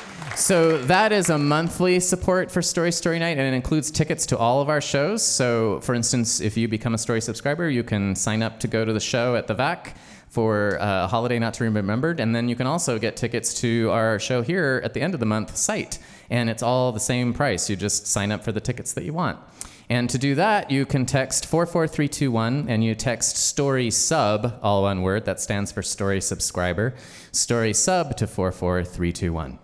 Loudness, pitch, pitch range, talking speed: -22 LUFS, 120 Hz, 110-145 Hz, 215 wpm